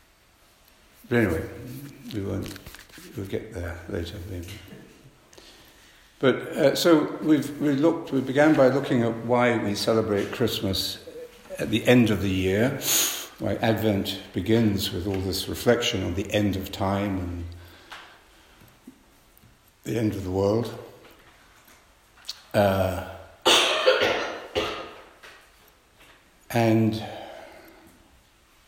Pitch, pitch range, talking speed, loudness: 105 Hz, 95-120 Hz, 105 wpm, -24 LUFS